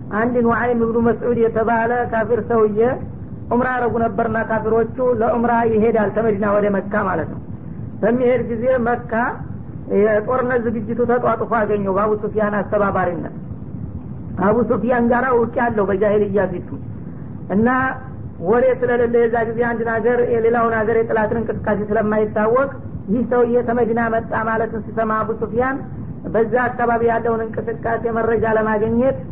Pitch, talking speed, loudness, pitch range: 230 Hz, 125 wpm, -18 LUFS, 220-240 Hz